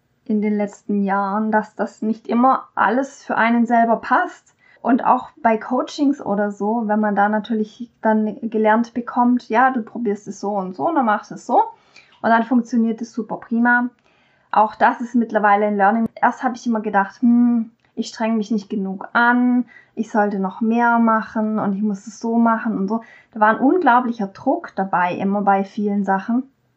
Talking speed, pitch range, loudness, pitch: 195 wpm, 210-240 Hz, -19 LUFS, 225 Hz